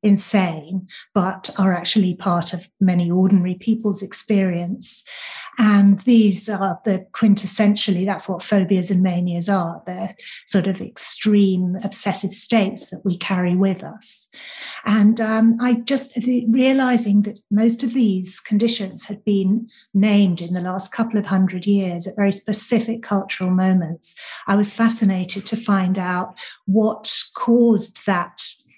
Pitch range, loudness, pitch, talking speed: 185-220 Hz, -19 LUFS, 200 Hz, 140 wpm